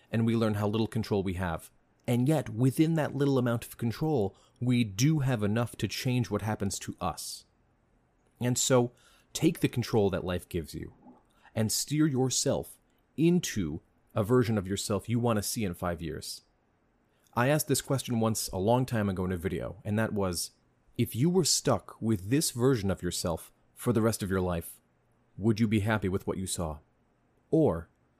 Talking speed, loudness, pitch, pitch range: 190 wpm, -30 LUFS, 115 Hz, 100-125 Hz